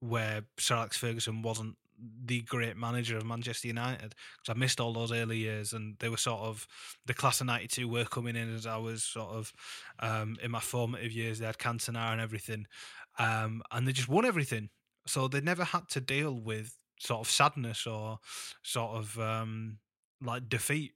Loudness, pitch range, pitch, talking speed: -34 LUFS, 110-125 Hz, 115 Hz, 195 wpm